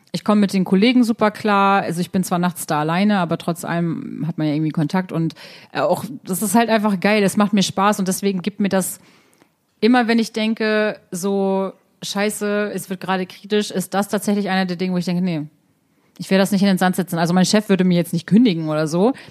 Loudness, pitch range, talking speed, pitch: -19 LUFS, 180-210 Hz, 235 wpm, 190 Hz